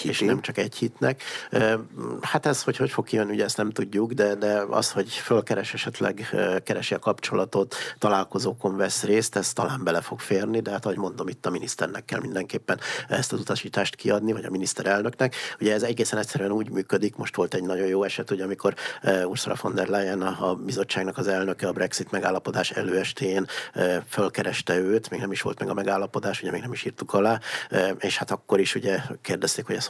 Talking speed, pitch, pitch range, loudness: 195 wpm, 100 Hz, 95-110 Hz, -26 LUFS